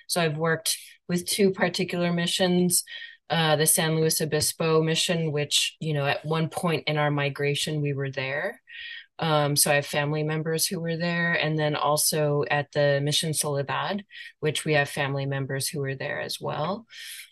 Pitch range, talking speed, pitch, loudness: 145-175 Hz, 175 wpm, 155 Hz, -25 LUFS